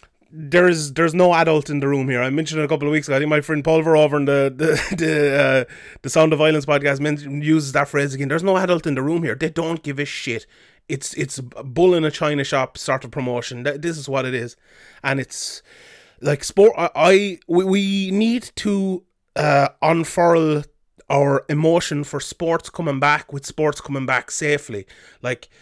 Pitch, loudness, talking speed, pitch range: 150 Hz, -19 LUFS, 205 wpm, 140-165 Hz